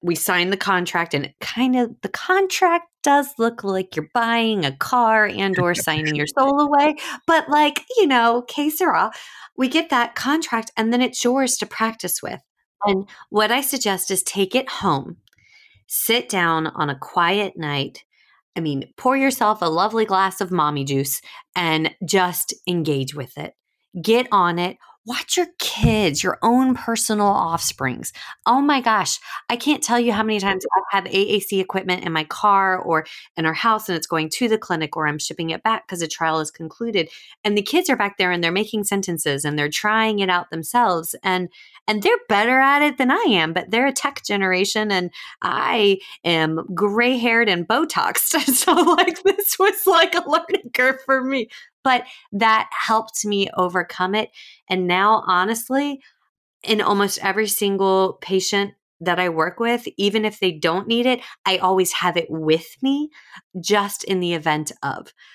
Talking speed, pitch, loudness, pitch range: 180 wpm, 205 Hz, -20 LUFS, 180-250 Hz